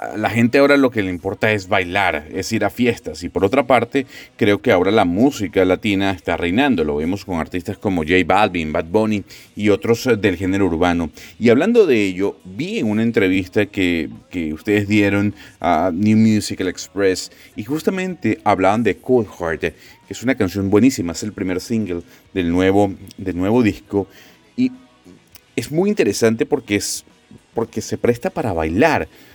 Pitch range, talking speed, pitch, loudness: 95-115 Hz, 175 wpm, 100 Hz, -18 LUFS